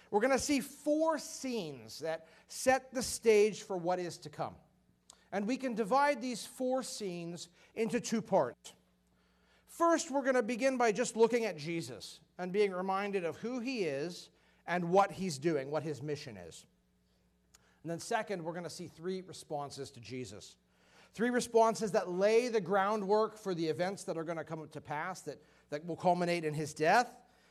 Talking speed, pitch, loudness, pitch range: 185 wpm, 185 Hz, -34 LUFS, 155-230 Hz